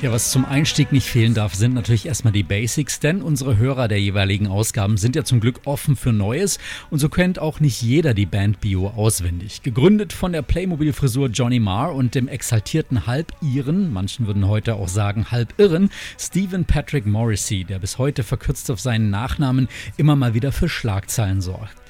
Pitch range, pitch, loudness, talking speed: 105-145 Hz, 125 Hz, -20 LUFS, 190 wpm